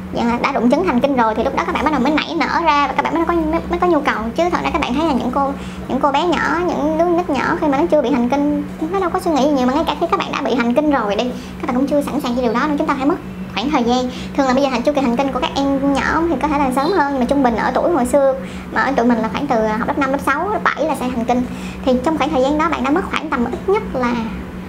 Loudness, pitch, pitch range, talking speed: -17 LUFS, 275 Hz, 250-305 Hz, 355 wpm